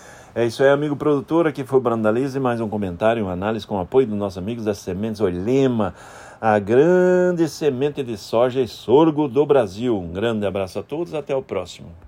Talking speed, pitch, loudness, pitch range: 200 wpm, 120 Hz, -20 LUFS, 105-140 Hz